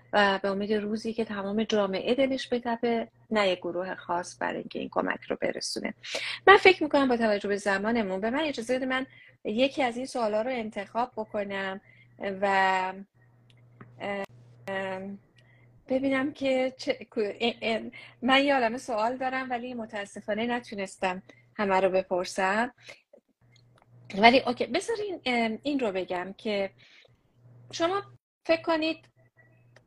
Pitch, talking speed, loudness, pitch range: 215 Hz, 125 wpm, -28 LUFS, 190-250 Hz